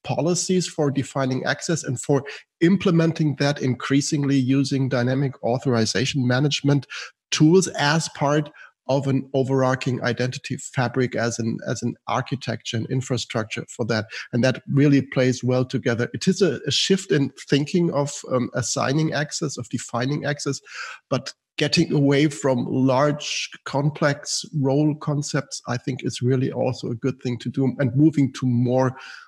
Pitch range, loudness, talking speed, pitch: 125-150 Hz, -22 LUFS, 150 wpm, 135 Hz